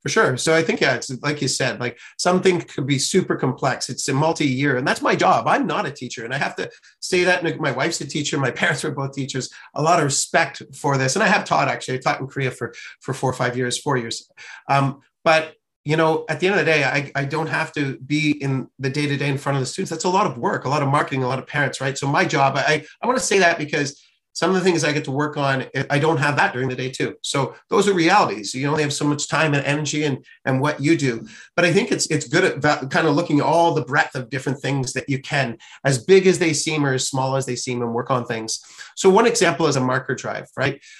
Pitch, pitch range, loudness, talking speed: 145 Hz, 130-160 Hz, -20 LUFS, 280 wpm